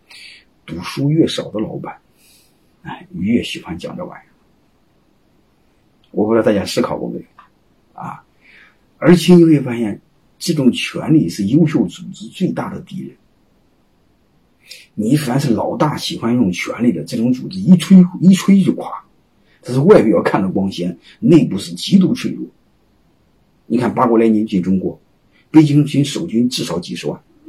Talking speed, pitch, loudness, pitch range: 225 characters per minute, 150 Hz, -15 LUFS, 115-180 Hz